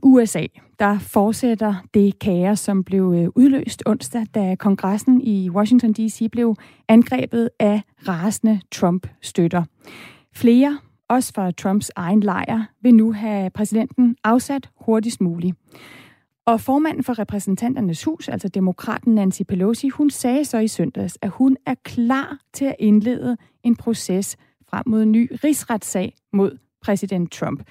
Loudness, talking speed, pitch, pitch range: -19 LUFS, 135 wpm, 220 Hz, 195-245 Hz